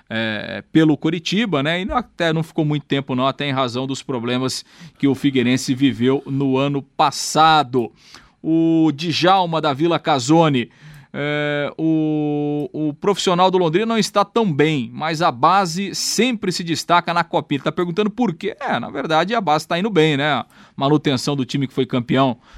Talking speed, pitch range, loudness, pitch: 175 wpm, 140-170 Hz, -19 LUFS, 155 Hz